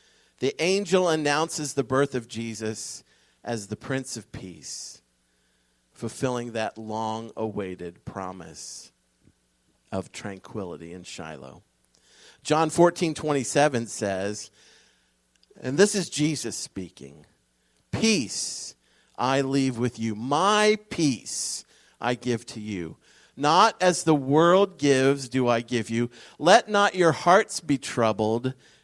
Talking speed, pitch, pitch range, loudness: 115 wpm, 120 Hz, 100-150 Hz, -25 LUFS